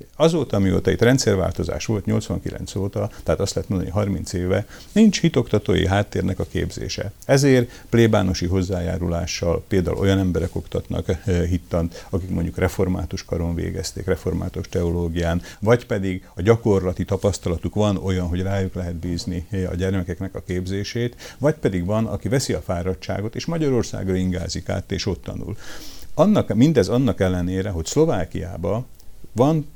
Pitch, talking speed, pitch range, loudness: 95 Hz, 145 wpm, 90-110 Hz, -22 LUFS